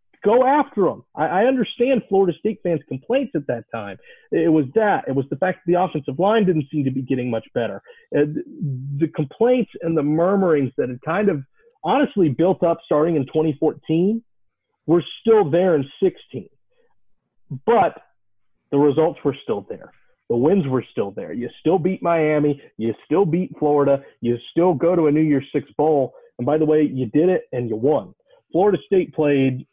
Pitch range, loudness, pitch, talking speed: 145-200 Hz, -20 LUFS, 165 Hz, 185 wpm